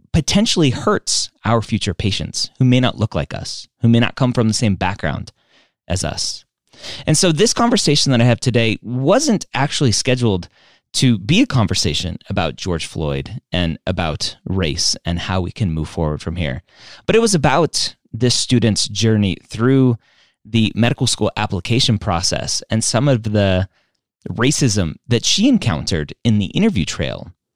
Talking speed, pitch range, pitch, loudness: 165 wpm, 95-130 Hz, 115 Hz, -17 LUFS